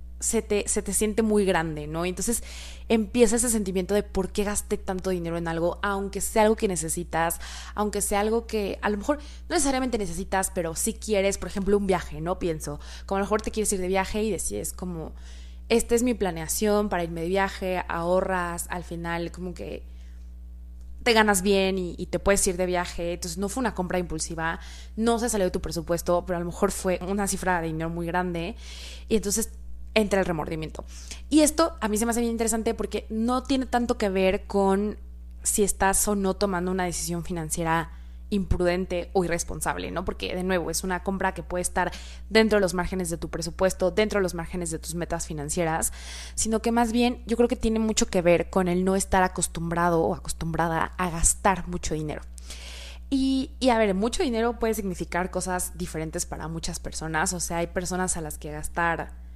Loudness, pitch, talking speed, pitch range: -26 LUFS, 185 Hz, 205 wpm, 170-210 Hz